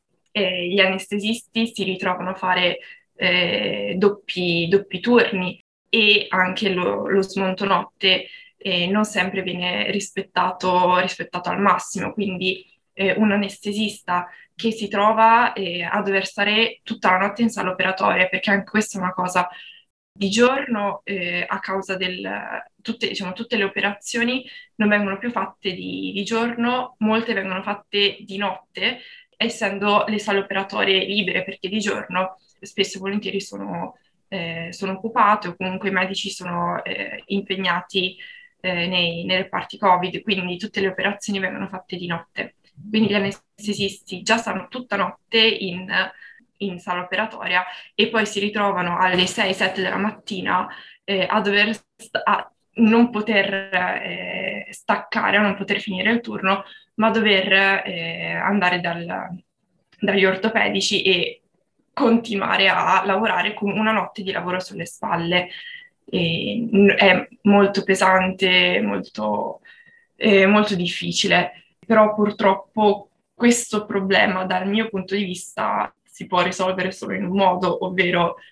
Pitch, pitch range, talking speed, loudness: 195 Hz, 185-215 Hz, 140 wpm, -20 LUFS